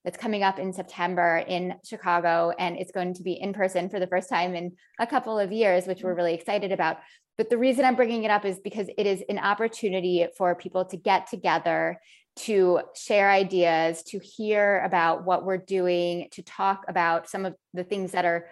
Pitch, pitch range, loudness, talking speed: 185 Hz, 180-205 Hz, -26 LUFS, 205 wpm